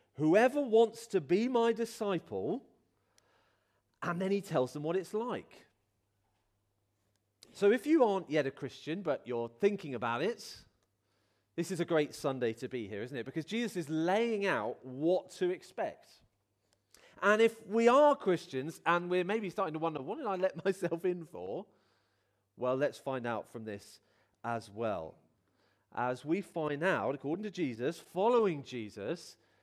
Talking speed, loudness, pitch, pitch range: 160 wpm, -33 LUFS, 165 Hz, 115-195 Hz